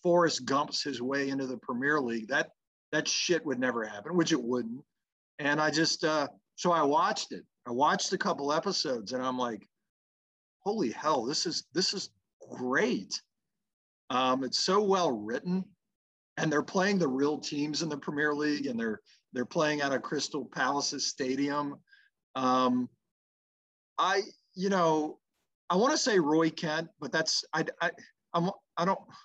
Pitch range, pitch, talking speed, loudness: 130-175 Hz, 150 Hz, 165 wpm, -30 LUFS